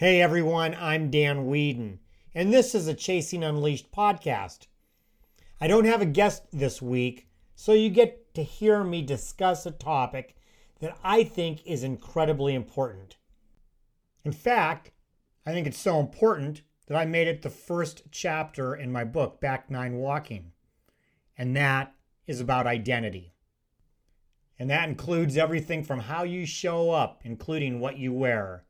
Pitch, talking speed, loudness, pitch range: 150 Hz, 150 wpm, -27 LUFS, 125-170 Hz